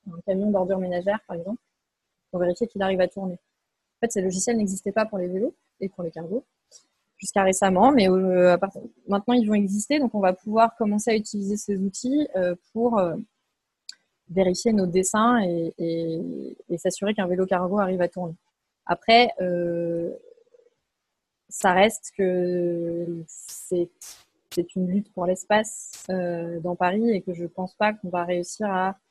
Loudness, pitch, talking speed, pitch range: -24 LUFS, 190 Hz, 150 wpm, 180-215 Hz